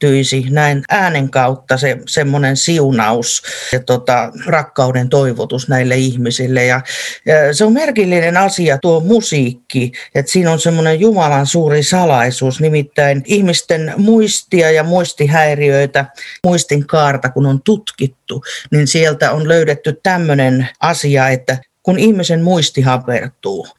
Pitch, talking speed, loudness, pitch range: 145 Hz, 120 wpm, -13 LUFS, 130-170 Hz